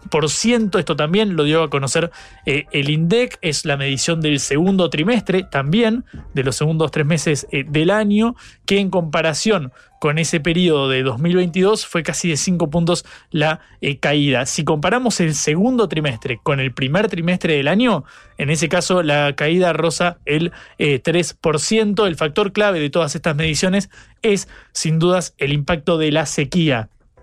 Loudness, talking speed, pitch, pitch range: -18 LUFS, 170 wpm, 165 Hz, 150-185 Hz